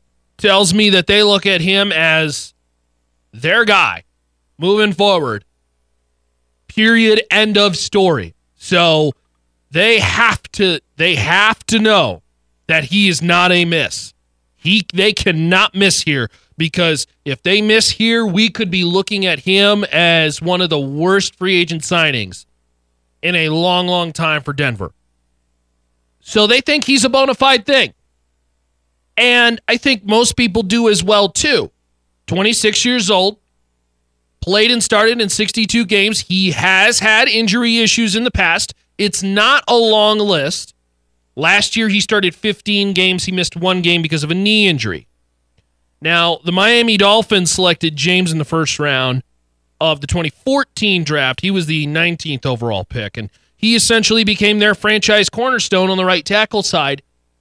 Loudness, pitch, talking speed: -13 LUFS, 180 Hz, 155 wpm